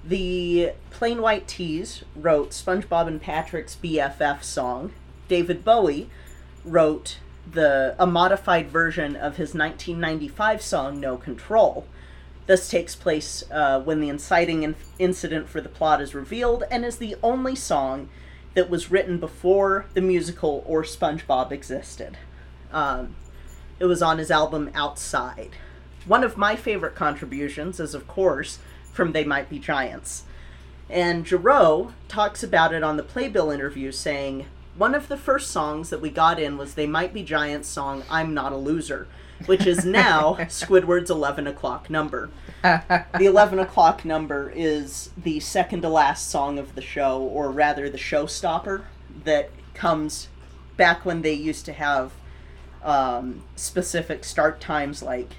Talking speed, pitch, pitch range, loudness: 150 wpm, 155 Hz, 140-180 Hz, -23 LUFS